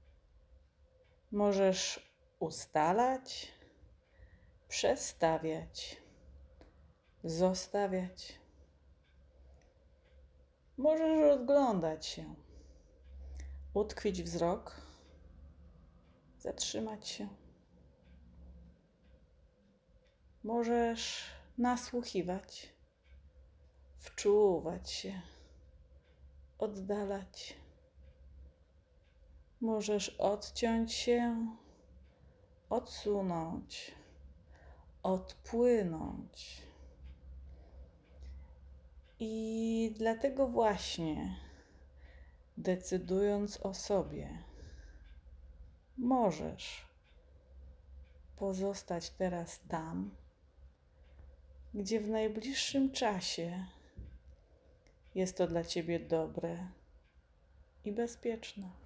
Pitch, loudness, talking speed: 80 Hz, -36 LUFS, 45 wpm